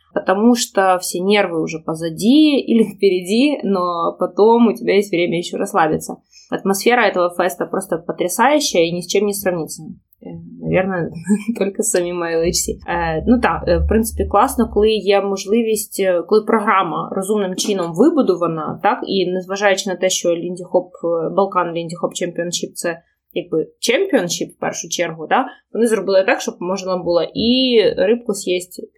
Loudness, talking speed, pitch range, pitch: -17 LUFS, 145 wpm, 175-225 Hz, 190 Hz